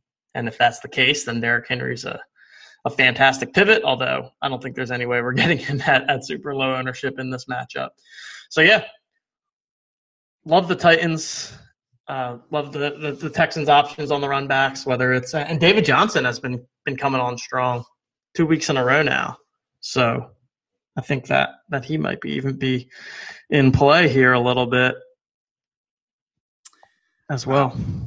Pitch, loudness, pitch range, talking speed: 135 Hz, -20 LUFS, 125-155 Hz, 175 wpm